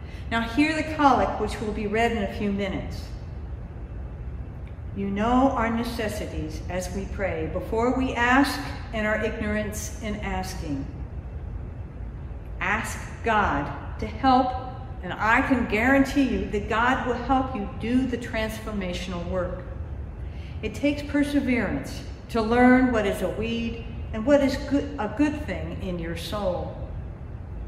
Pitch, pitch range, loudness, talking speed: 235 Hz, 210-260 Hz, -25 LUFS, 140 wpm